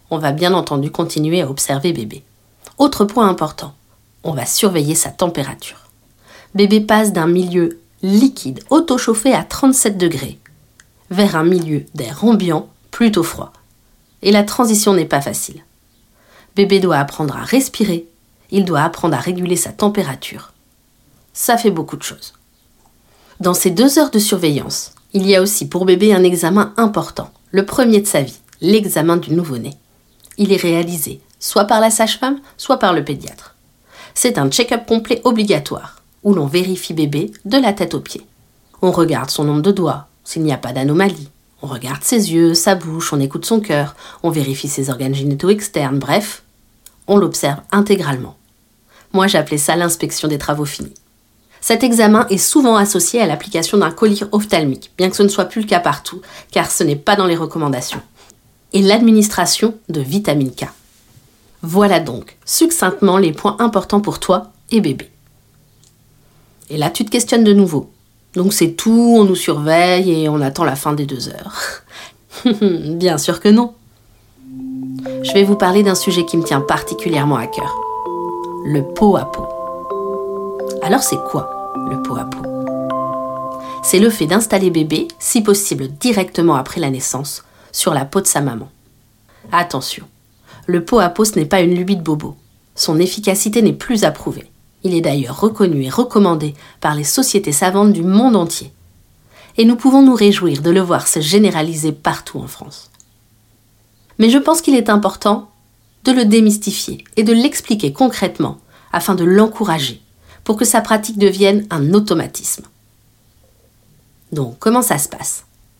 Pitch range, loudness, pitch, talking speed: 135-205 Hz, -15 LUFS, 170 Hz, 165 wpm